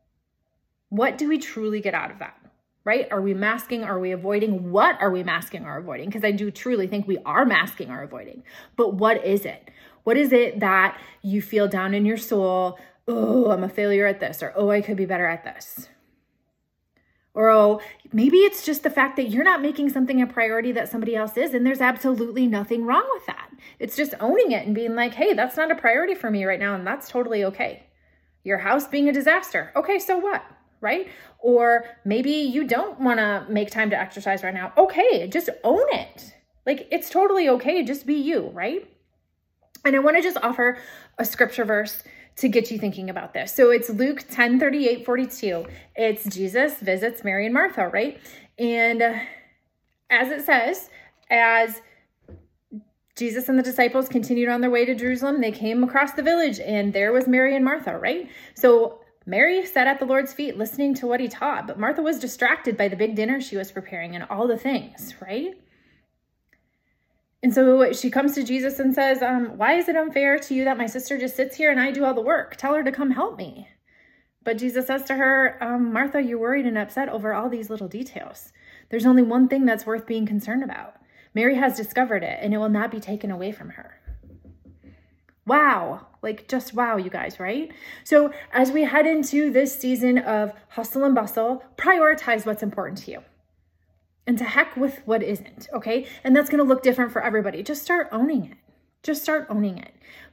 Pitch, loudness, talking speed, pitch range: 245 Hz, -22 LUFS, 200 wpm, 215-275 Hz